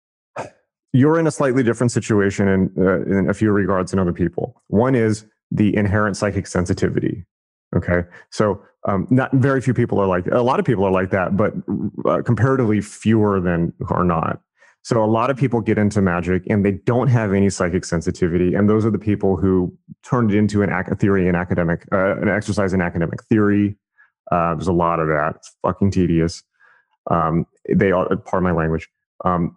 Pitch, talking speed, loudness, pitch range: 100 Hz, 195 wpm, -19 LUFS, 90-110 Hz